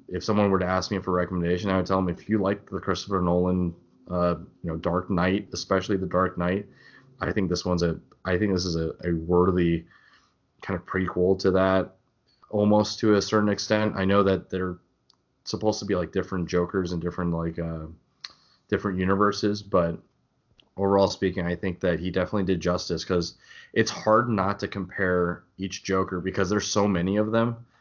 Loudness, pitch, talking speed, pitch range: -26 LUFS, 95 Hz, 195 wpm, 90-100 Hz